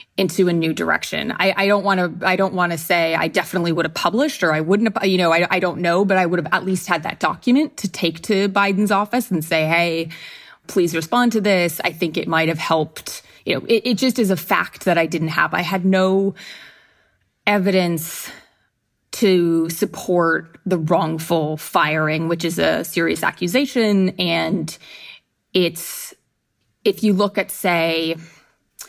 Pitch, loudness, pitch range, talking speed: 180 Hz, -19 LUFS, 165-200 Hz, 185 wpm